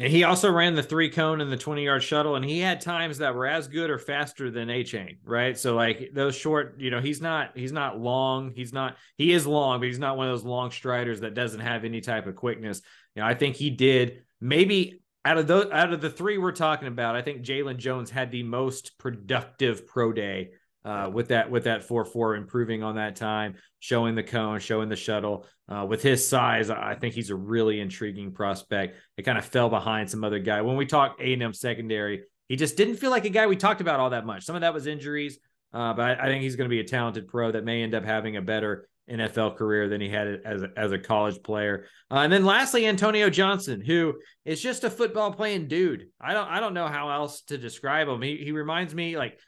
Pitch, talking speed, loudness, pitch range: 125 Hz, 245 wpm, -26 LUFS, 110-150 Hz